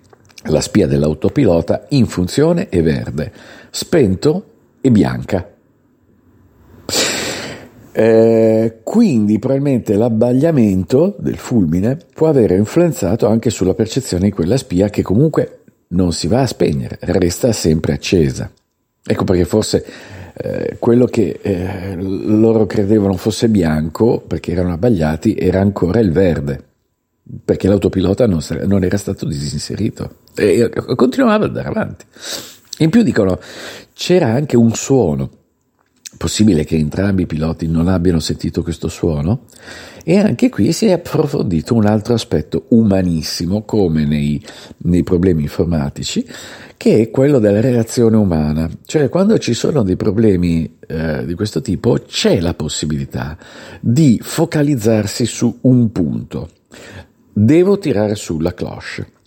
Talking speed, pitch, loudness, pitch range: 125 wpm, 105 Hz, -15 LUFS, 85-120 Hz